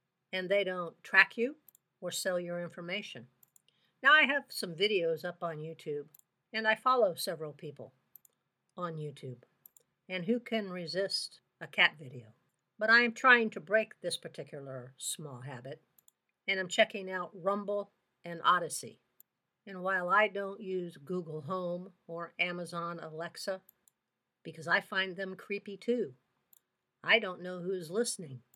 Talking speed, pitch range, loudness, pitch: 145 wpm, 165-200 Hz, -32 LUFS, 180 Hz